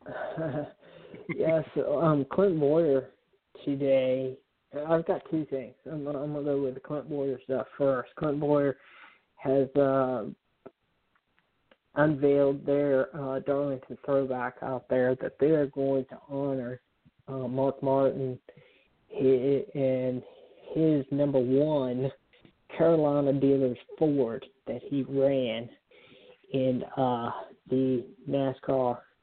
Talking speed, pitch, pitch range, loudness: 115 wpm, 135 Hz, 130-145 Hz, -28 LUFS